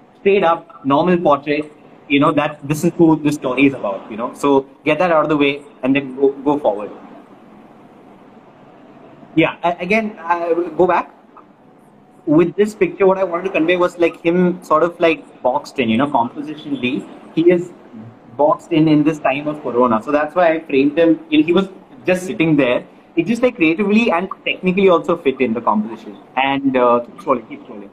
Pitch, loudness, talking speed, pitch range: 160 Hz, -16 LUFS, 195 wpm, 140-180 Hz